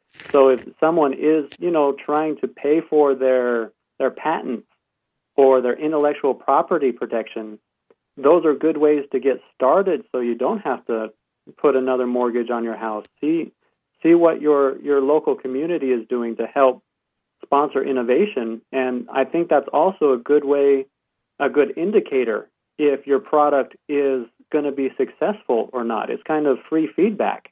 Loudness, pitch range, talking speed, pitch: -20 LUFS, 125-150 Hz, 165 wpm, 140 Hz